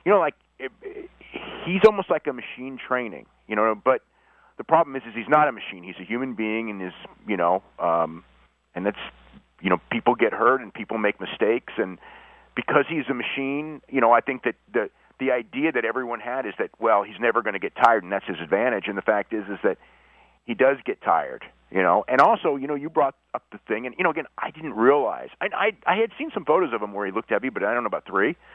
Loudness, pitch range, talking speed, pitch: -24 LUFS, 110-180 Hz, 250 wpm, 135 Hz